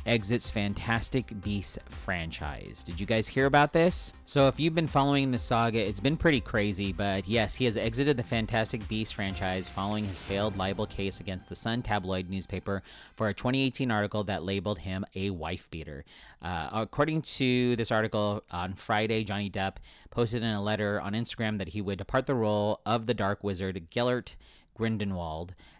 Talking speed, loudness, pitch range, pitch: 180 wpm, -30 LUFS, 95-120 Hz, 105 Hz